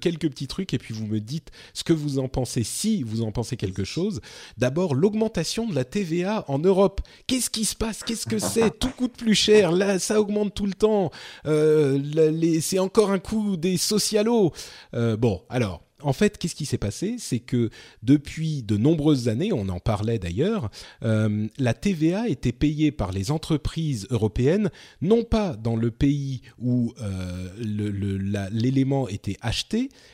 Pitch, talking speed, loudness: 150 Hz, 185 wpm, -24 LUFS